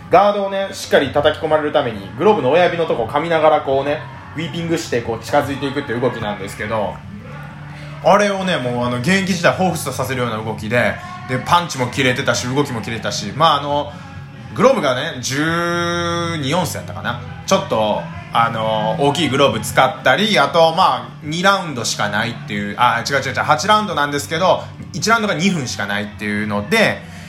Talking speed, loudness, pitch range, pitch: 390 characters per minute, -17 LUFS, 120-165 Hz, 145 Hz